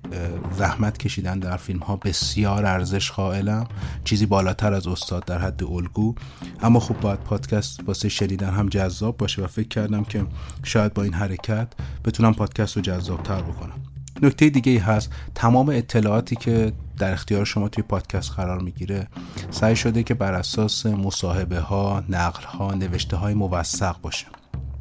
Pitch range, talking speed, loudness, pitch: 90-110 Hz, 155 wpm, -23 LUFS, 100 Hz